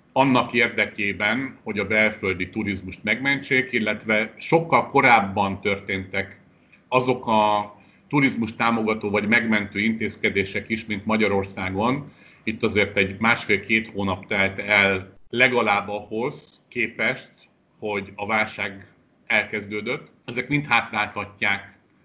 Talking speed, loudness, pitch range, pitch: 105 wpm, -22 LUFS, 100-115 Hz, 105 Hz